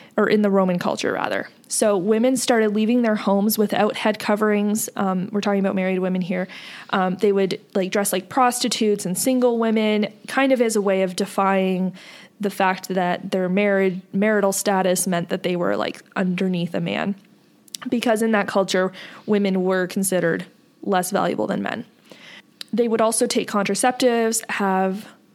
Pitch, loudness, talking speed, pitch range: 205 Hz, -21 LUFS, 170 wpm, 190-220 Hz